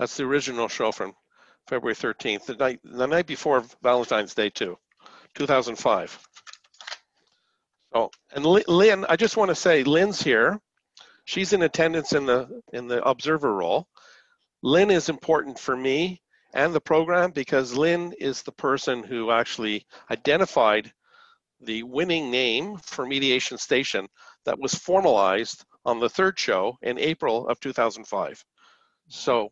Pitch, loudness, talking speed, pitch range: 150 Hz, -24 LUFS, 140 wpm, 125-180 Hz